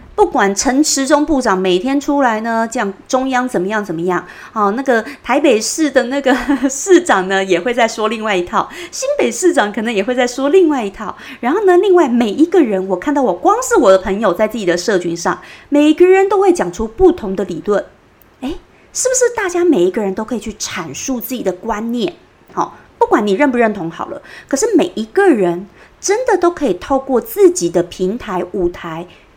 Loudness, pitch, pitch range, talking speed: -14 LUFS, 250 Hz, 195-320 Hz, 300 characters per minute